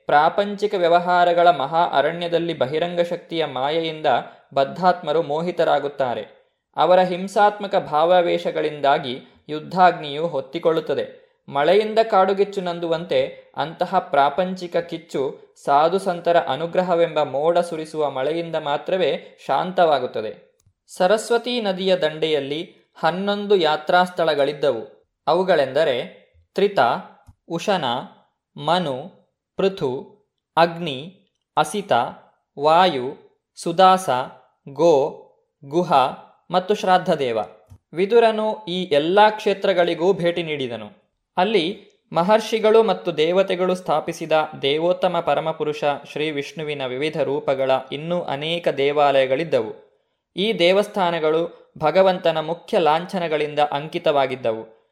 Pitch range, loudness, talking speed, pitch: 150-195 Hz, -20 LUFS, 80 wpm, 170 Hz